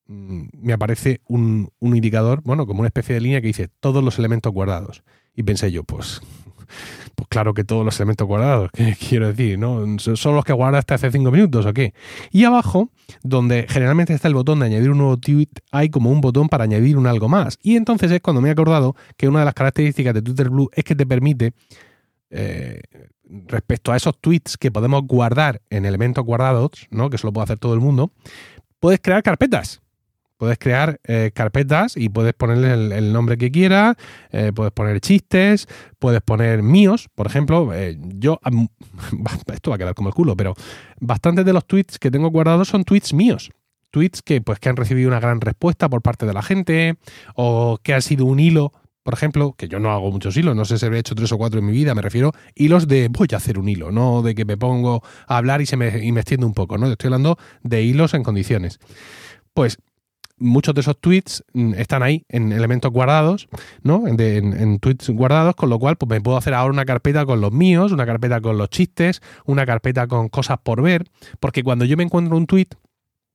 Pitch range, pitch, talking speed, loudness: 115-145 Hz, 125 Hz, 215 wpm, -18 LUFS